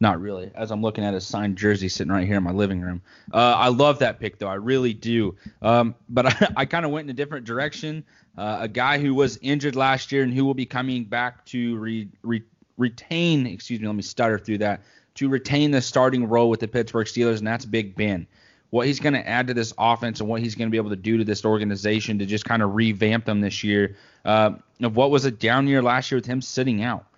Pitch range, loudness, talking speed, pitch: 105-130 Hz, -23 LUFS, 255 wpm, 115 Hz